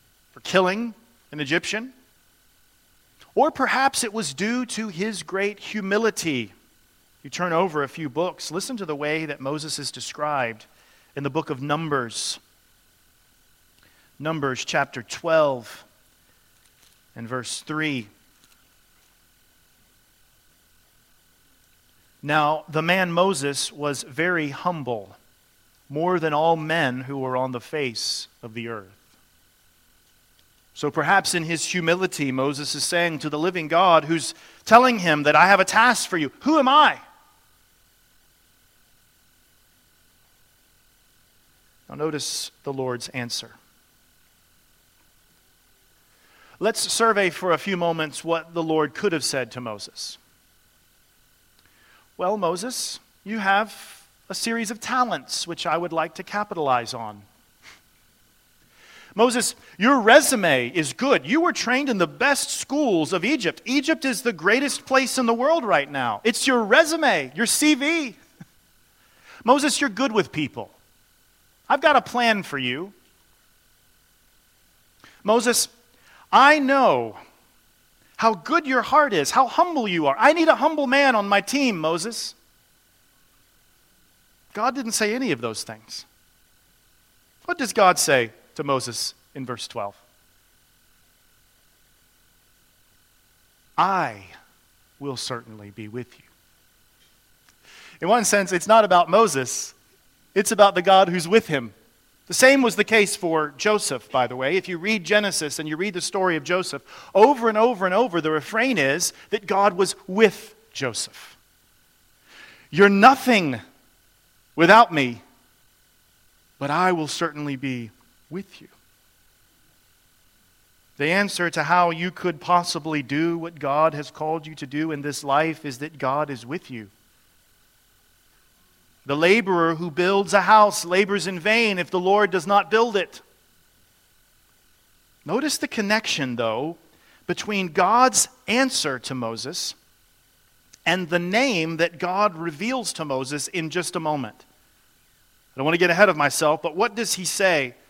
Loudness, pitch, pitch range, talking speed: -21 LUFS, 175 Hz, 145-220 Hz, 135 wpm